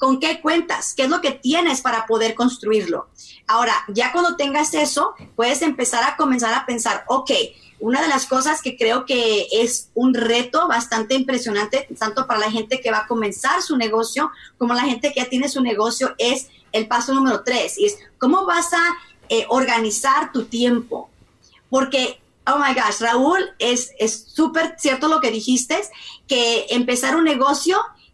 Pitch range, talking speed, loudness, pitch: 235-300 Hz, 175 wpm, -19 LUFS, 260 Hz